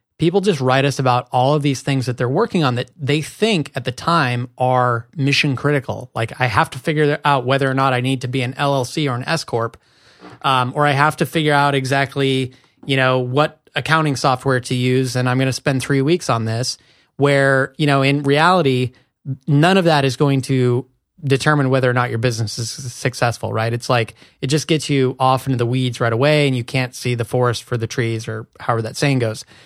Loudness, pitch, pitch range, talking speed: -18 LUFS, 130 Hz, 125-145 Hz, 225 wpm